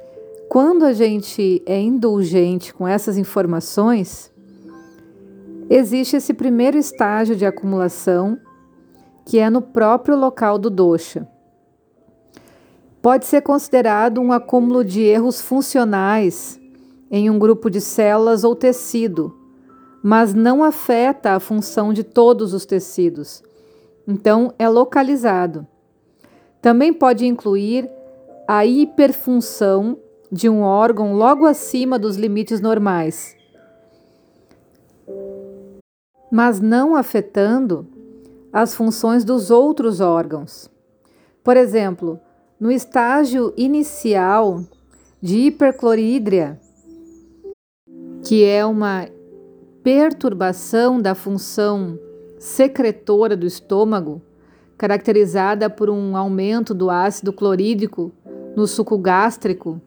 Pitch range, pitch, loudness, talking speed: 190-250 Hz, 215 Hz, -16 LUFS, 95 wpm